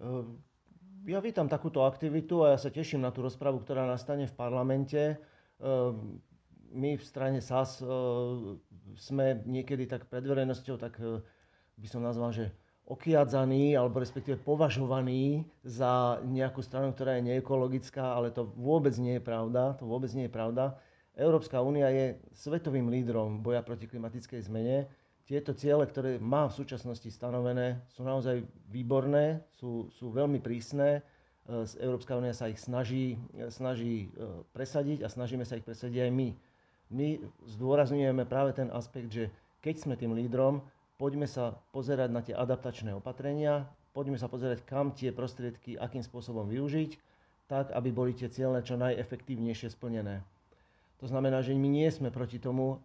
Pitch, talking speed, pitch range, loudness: 130 Hz, 145 wpm, 120-135 Hz, -33 LUFS